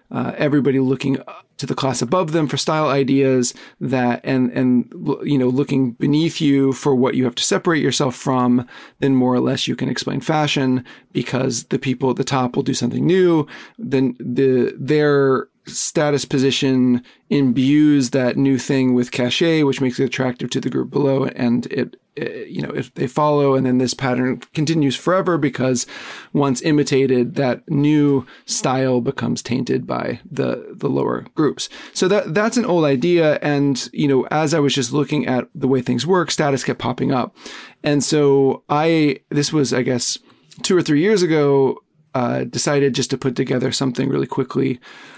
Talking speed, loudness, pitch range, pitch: 180 wpm, -18 LUFS, 130-150 Hz, 135 Hz